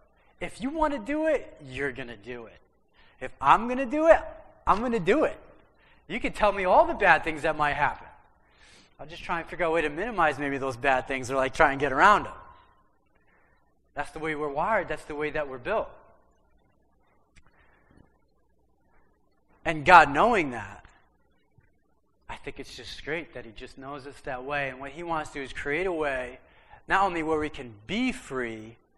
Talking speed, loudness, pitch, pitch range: 205 wpm, -26 LUFS, 150 Hz, 130-175 Hz